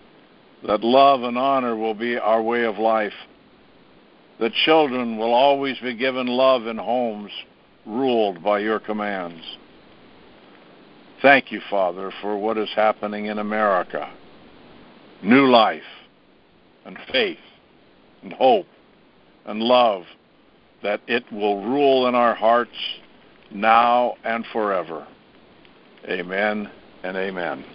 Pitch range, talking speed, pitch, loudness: 105-125 Hz, 115 wpm, 115 Hz, -20 LUFS